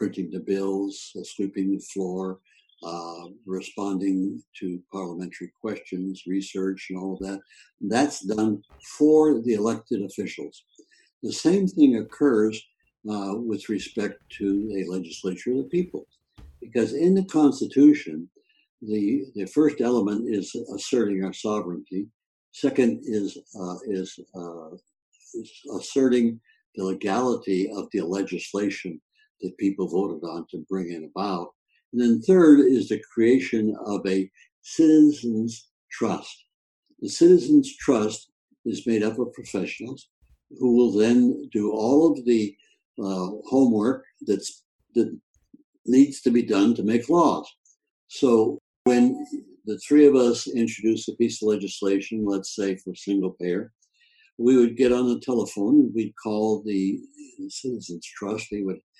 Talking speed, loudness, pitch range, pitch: 135 wpm, -23 LUFS, 95-140 Hz, 110 Hz